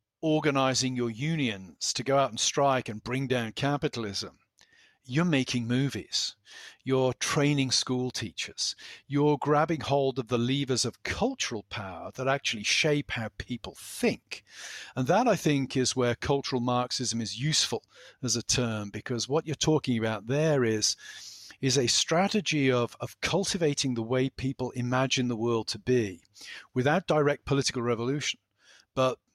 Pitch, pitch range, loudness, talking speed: 130 Hz, 120-145 Hz, -28 LUFS, 150 wpm